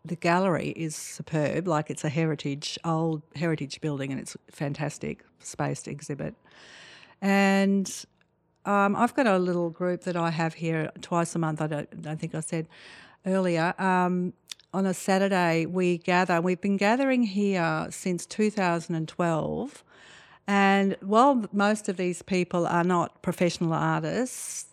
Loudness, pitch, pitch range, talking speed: -27 LUFS, 175 Hz, 160-195 Hz, 150 wpm